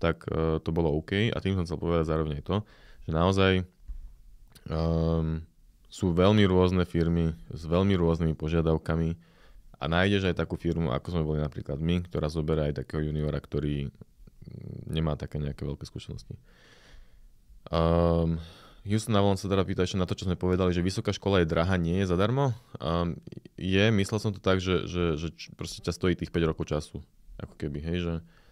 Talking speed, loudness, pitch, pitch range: 175 wpm, -28 LUFS, 85 Hz, 80-95 Hz